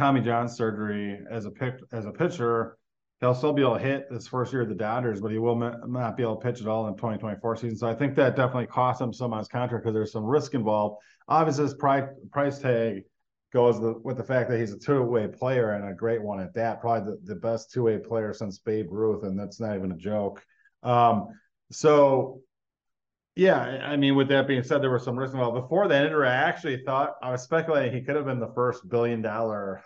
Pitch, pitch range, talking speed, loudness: 120 Hz, 110-130 Hz, 245 wpm, -26 LUFS